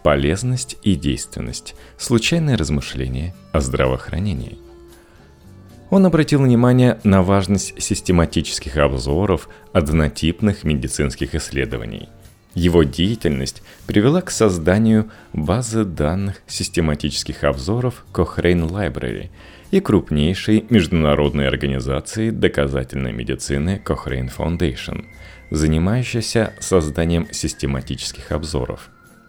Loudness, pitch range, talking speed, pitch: -19 LUFS, 70-105 Hz, 80 wpm, 85 Hz